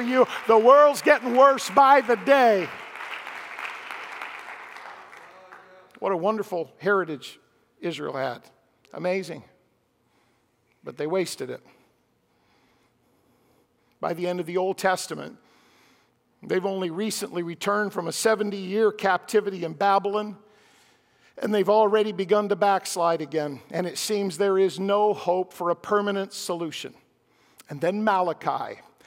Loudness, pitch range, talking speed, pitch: -24 LUFS, 180-215 Hz, 120 wpm, 200 Hz